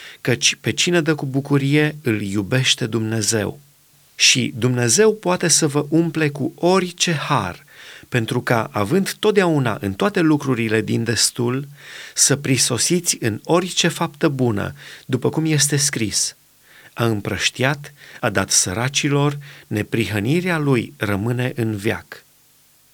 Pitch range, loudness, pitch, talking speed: 115-155 Hz, -19 LUFS, 135 Hz, 125 wpm